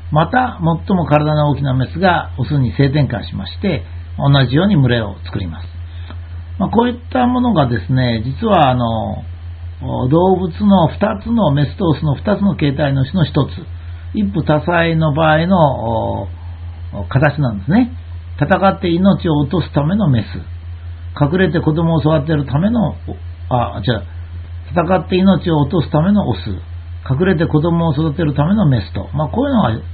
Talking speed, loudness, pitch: 295 characters per minute, -15 LUFS, 140 Hz